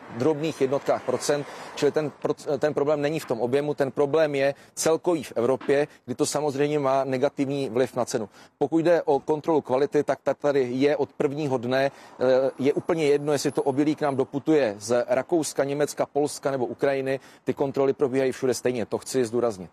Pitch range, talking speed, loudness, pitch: 130-150 Hz, 180 wpm, -25 LUFS, 140 Hz